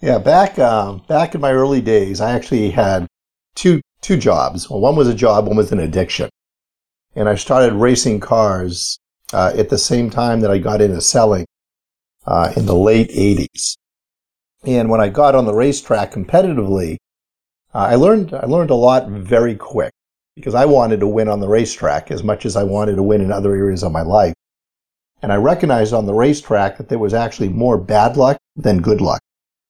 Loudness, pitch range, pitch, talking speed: -15 LUFS, 95-120 Hz, 105 Hz, 195 wpm